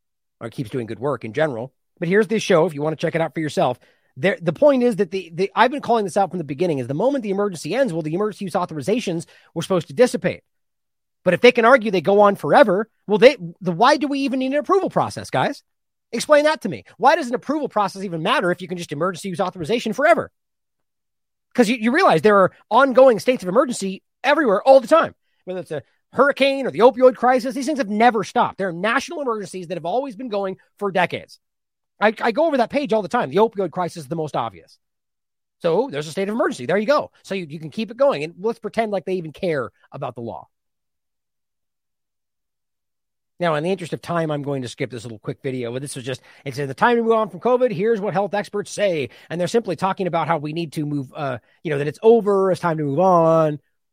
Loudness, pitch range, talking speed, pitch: -20 LUFS, 165-235 Hz, 245 wpm, 195 Hz